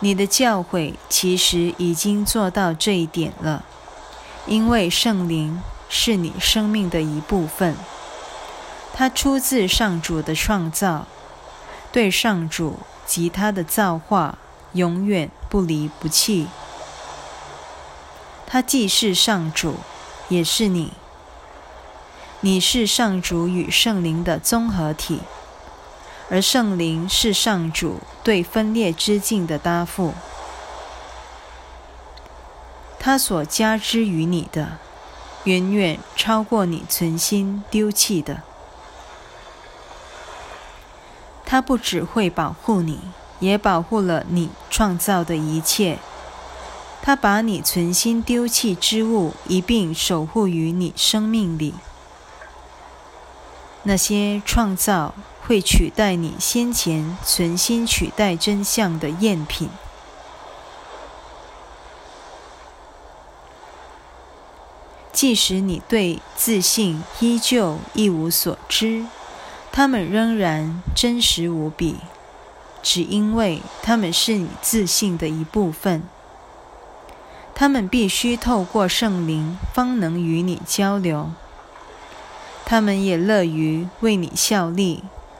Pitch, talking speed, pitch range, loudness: 180 Hz, 145 characters per minute, 160-215 Hz, -19 LUFS